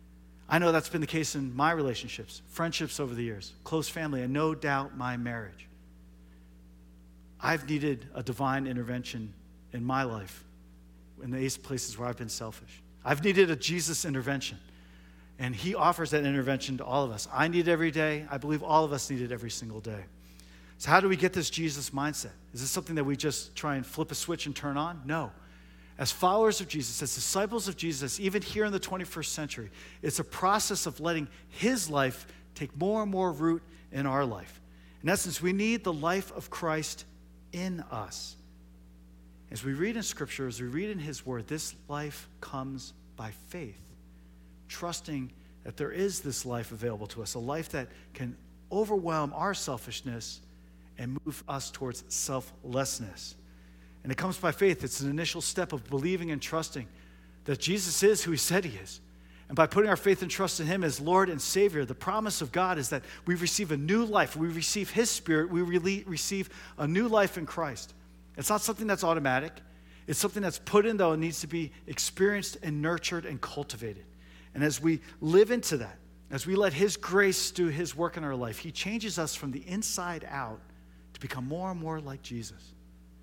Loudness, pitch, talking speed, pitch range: -31 LUFS, 145 Hz, 195 wpm, 110-170 Hz